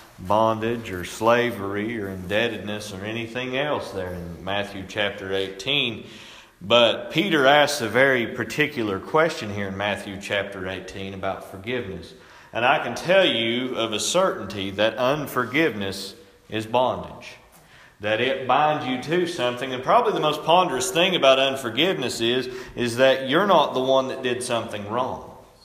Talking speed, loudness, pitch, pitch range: 150 wpm, -22 LUFS, 120 Hz, 100-130 Hz